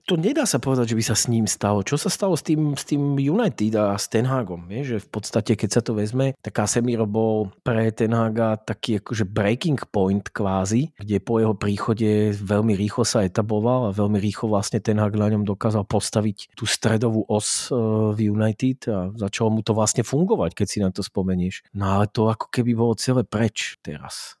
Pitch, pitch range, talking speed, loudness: 110 Hz, 105-120 Hz, 205 wpm, -22 LUFS